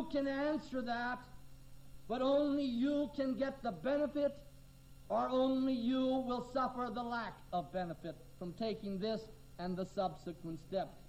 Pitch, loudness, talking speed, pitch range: 235 Hz, -38 LUFS, 140 wpm, 170-260 Hz